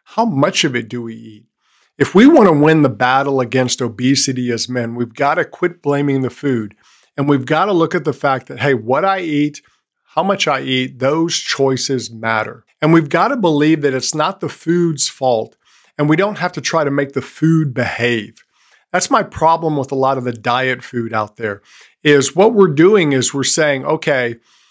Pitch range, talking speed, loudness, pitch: 125-160 Hz, 210 wpm, -15 LUFS, 140 Hz